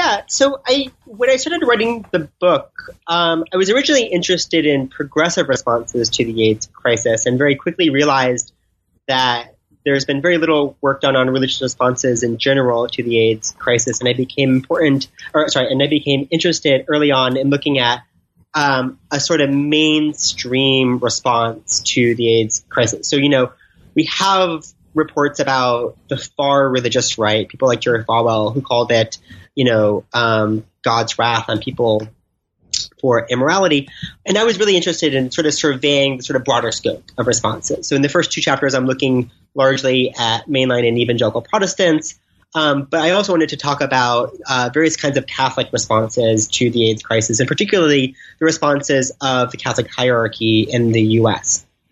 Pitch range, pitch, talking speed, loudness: 115-150 Hz, 130 Hz, 175 wpm, -16 LUFS